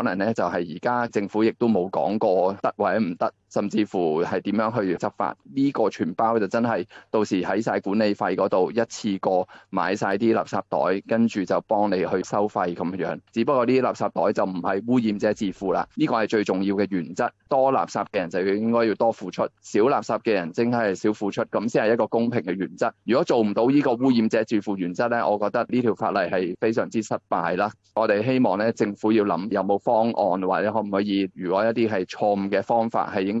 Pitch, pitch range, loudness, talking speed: 110 Hz, 100-115 Hz, -23 LUFS, 325 characters per minute